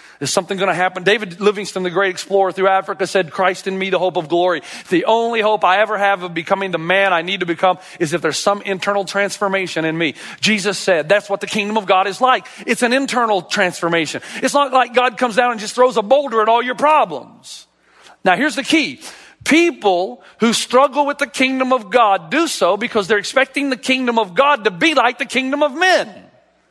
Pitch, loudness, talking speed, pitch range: 205 Hz, -16 LUFS, 220 wpm, 185-255 Hz